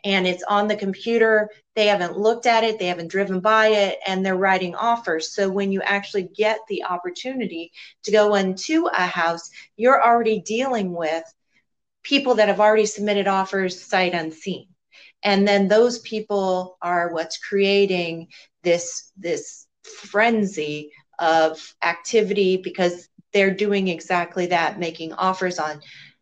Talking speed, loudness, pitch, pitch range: 145 wpm, -21 LUFS, 195 Hz, 175-215 Hz